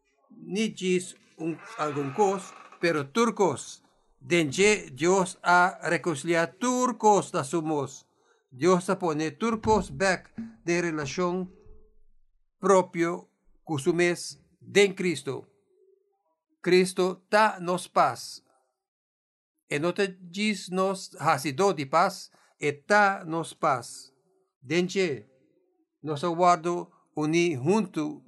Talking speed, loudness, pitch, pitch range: 95 wpm, -26 LUFS, 180 Hz, 165-200 Hz